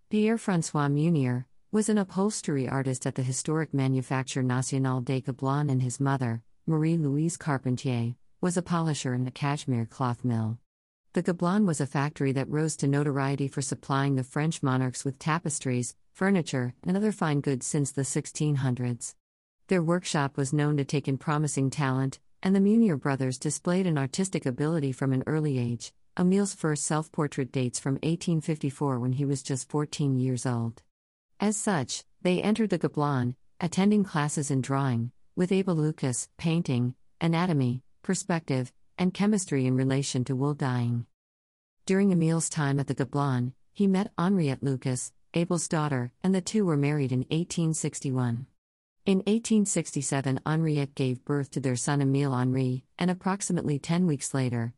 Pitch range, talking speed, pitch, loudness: 130-165 Hz, 155 wpm, 140 Hz, -28 LUFS